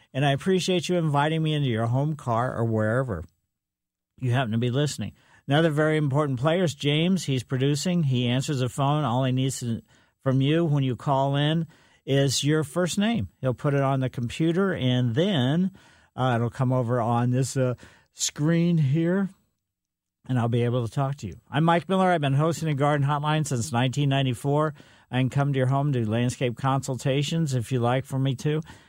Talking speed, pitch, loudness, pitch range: 195 wpm, 135 Hz, -25 LUFS, 125-155 Hz